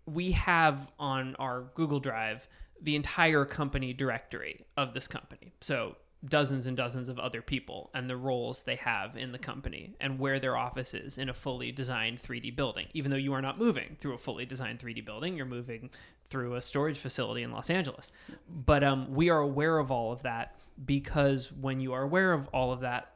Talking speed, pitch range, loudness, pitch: 200 wpm, 125-145 Hz, -32 LUFS, 135 Hz